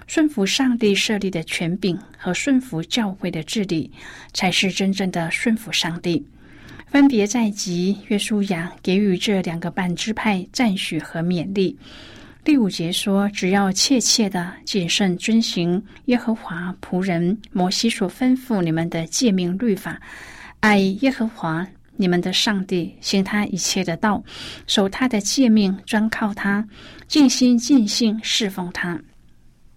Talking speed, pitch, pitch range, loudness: 215 characters per minute, 195 Hz, 180-220 Hz, -20 LUFS